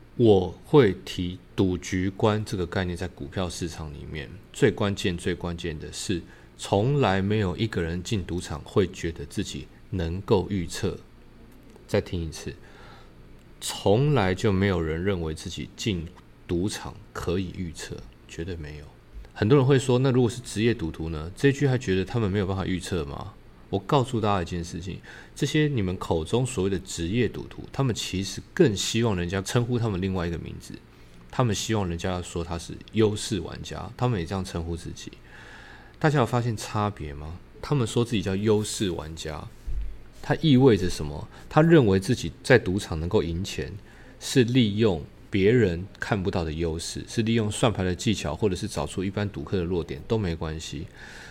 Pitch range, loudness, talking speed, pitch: 85-110 Hz, -26 LUFS, 270 characters per minute, 95 Hz